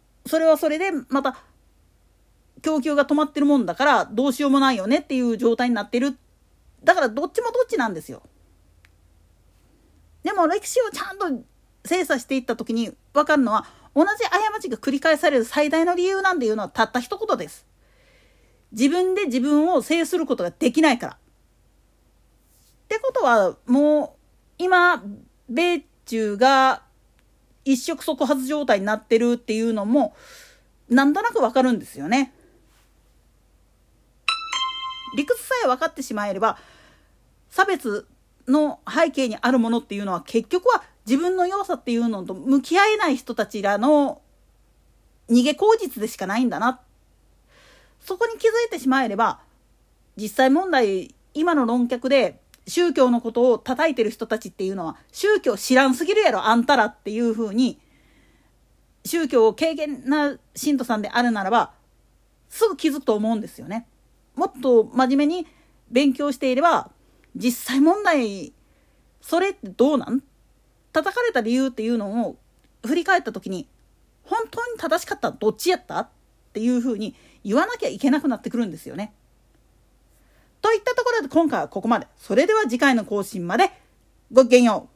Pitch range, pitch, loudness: 230-335 Hz, 275 Hz, -21 LUFS